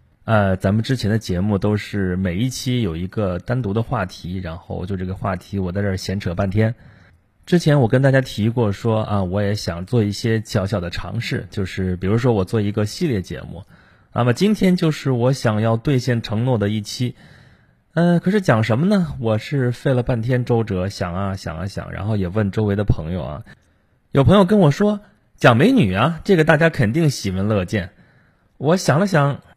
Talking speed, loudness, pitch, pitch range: 290 characters per minute, -19 LUFS, 110 Hz, 100-130 Hz